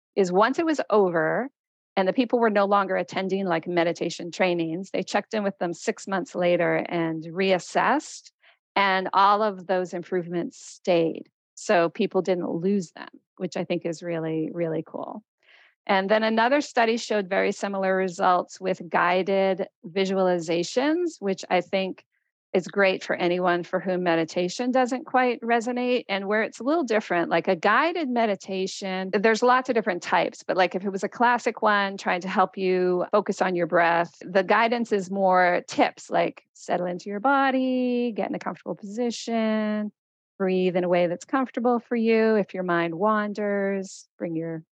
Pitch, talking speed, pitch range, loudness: 195 Hz, 170 wpm, 180-225 Hz, -24 LUFS